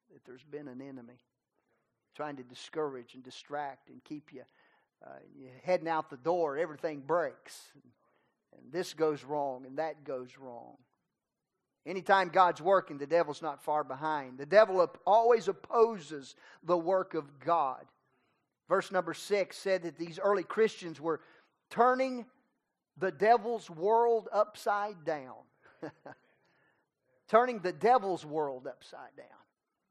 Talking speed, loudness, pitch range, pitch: 135 wpm, -31 LUFS, 145-195 Hz, 165 Hz